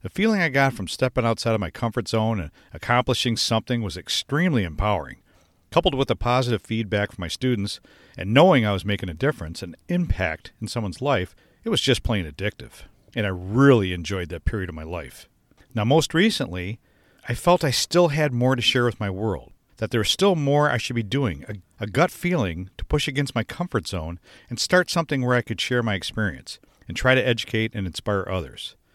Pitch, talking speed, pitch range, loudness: 115 Hz, 205 wpm, 95-130 Hz, -23 LUFS